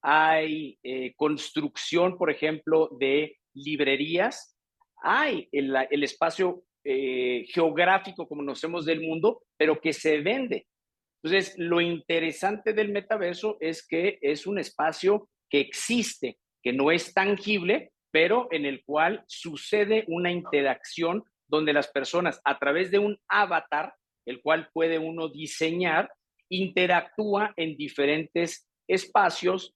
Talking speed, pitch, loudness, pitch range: 125 wpm, 165 Hz, -26 LUFS, 150-195 Hz